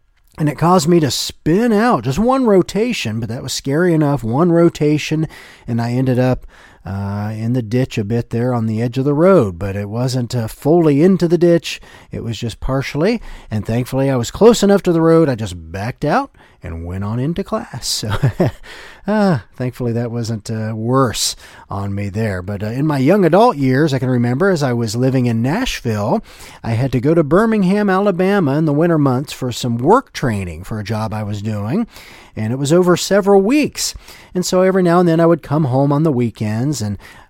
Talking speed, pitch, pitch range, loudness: 210 wpm, 135 Hz, 115-175 Hz, -16 LUFS